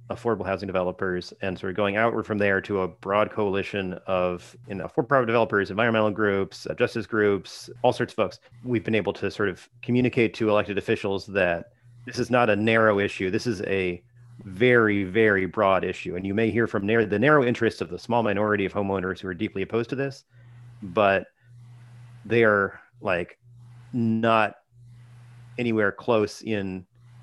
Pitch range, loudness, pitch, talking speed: 100-120 Hz, -24 LUFS, 110 Hz, 175 wpm